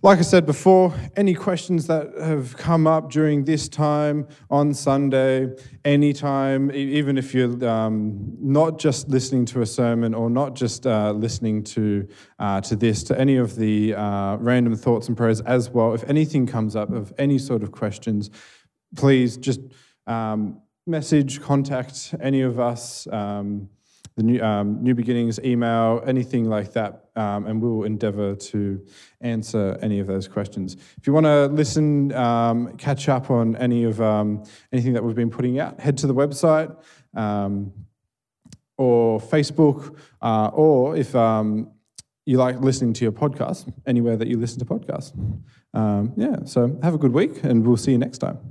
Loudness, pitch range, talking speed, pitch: -21 LUFS, 110-140 Hz, 170 wpm, 125 Hz